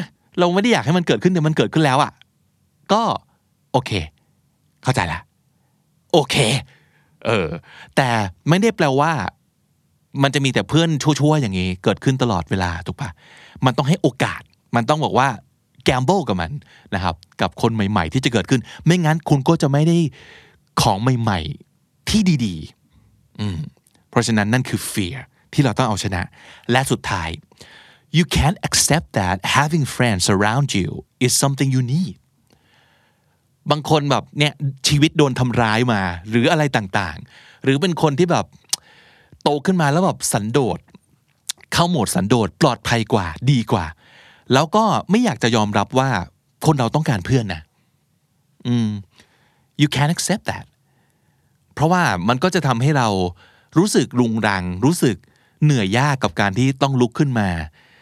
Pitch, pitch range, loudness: 130 Hz, 110-150 Hz, -19 LUFS